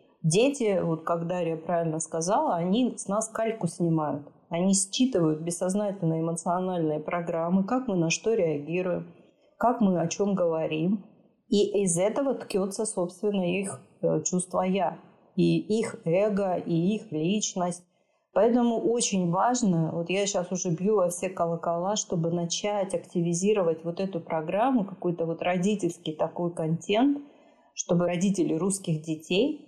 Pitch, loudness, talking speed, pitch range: 180 Hz, -27 LUFS, 135 wpm, 170-210 Hz